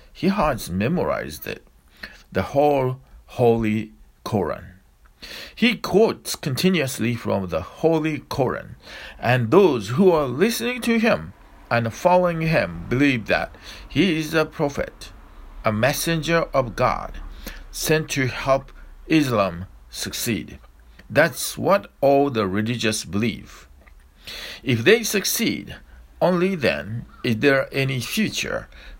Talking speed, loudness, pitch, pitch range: 115 wpm, -21 LUFS, 130 Hz, 100-160 Hz